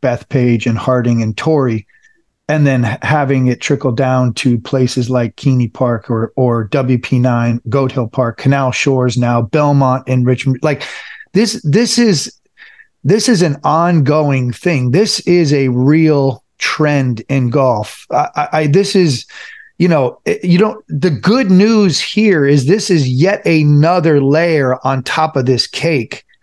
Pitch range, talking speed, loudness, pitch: 125-165 Hz, 155 wpm, -13 LUFS, 140 Hz